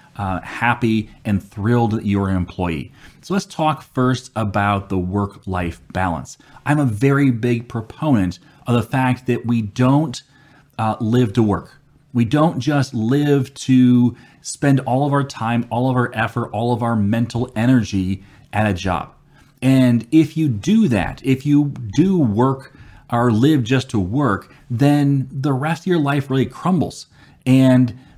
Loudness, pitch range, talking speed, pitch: -18 LUFS, 115-140 Hz, 165 wpm, 125 Hz